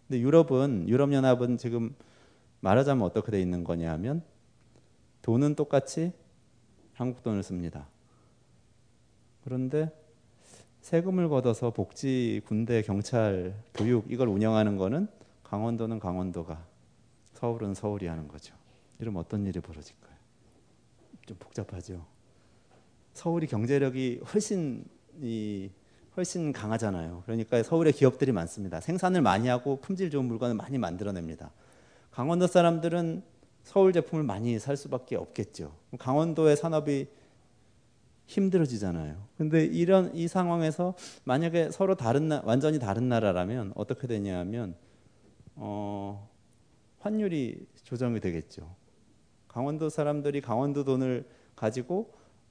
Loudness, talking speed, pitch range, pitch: -29 LUFS, 280 characters per minute, 105-145 Hz, 120 Hz